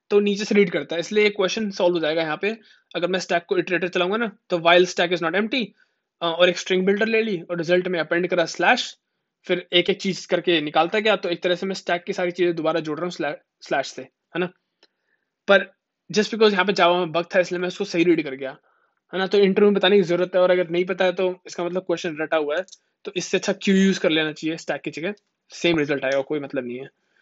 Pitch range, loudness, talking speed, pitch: 170-195 Hz, -22 LUFS, 260 wpm, 180 Hz